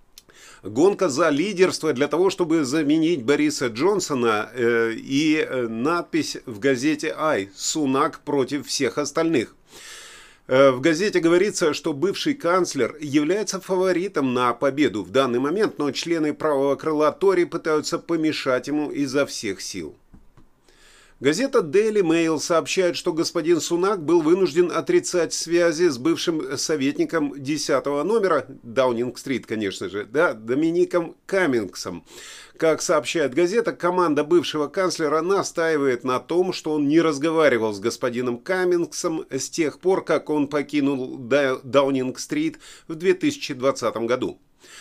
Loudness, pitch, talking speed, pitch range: -22 LUFS, 165 Hz, 120 wpm, 140-205 Hz